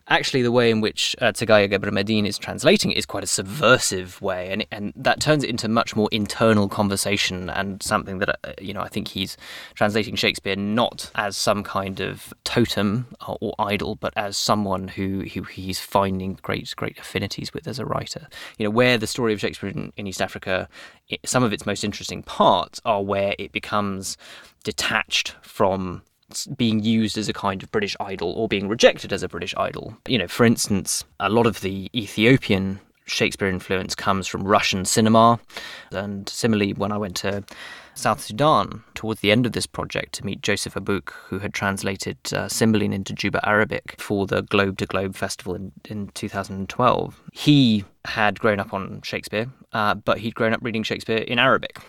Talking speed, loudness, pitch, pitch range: 190 wpm, -22 LUFS, 100 Hz, 95-110 Hz